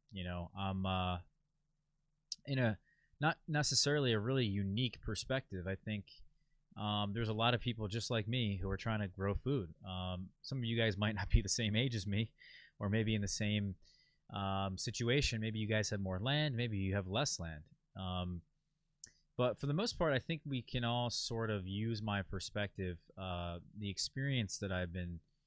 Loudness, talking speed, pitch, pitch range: -38 LUFS, 195 wpm, 110 Hz, 95-125 Hz